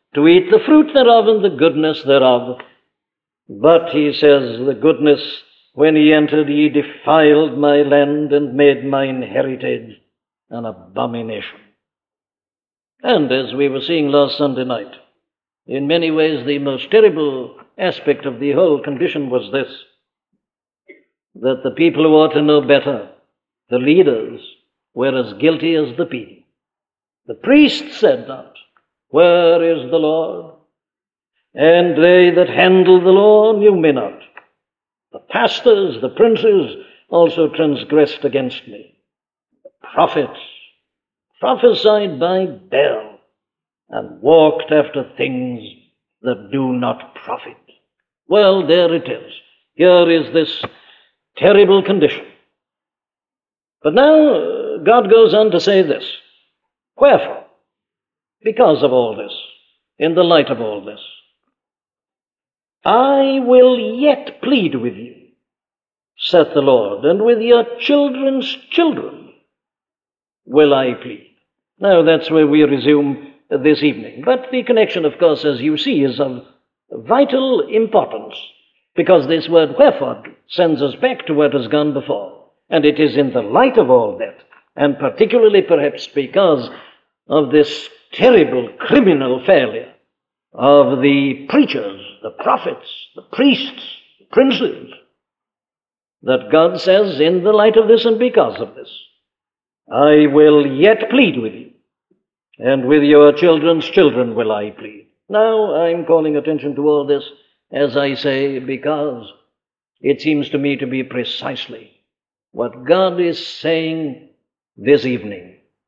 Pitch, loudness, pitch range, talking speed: 155 Hz, -14 LUFS, 145-220 Hz, 130 wpm